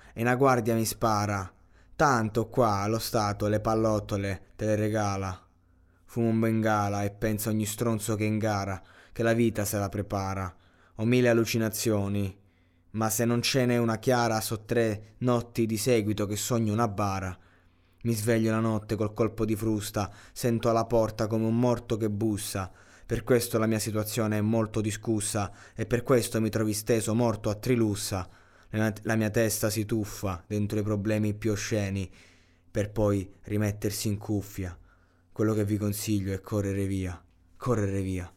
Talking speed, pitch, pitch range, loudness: 165 wpm, 105 Hz, 100-115 Hz, -28 LUFS